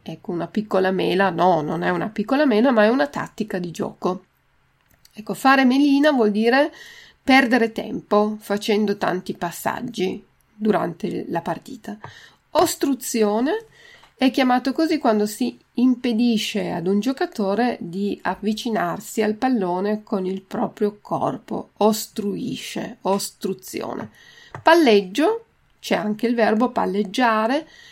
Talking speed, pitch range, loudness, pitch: 120 wpm, 200-260 Hz, -21 LUFS, 220 Hz